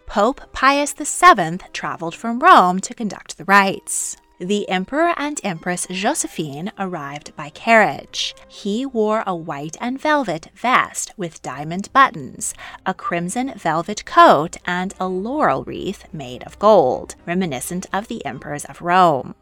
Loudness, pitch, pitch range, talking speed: -18 LUFS, 190 Hz, 170-245 Hz, 140 wpm